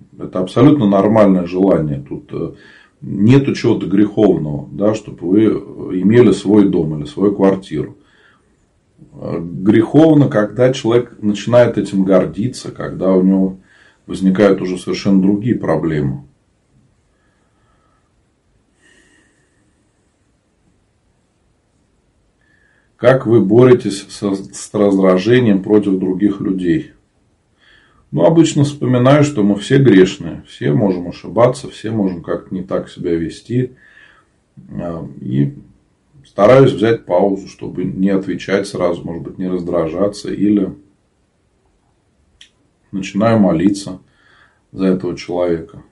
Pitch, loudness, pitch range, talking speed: 100 Hz, -14 LUFS, 90-110 Hz, 95 wpm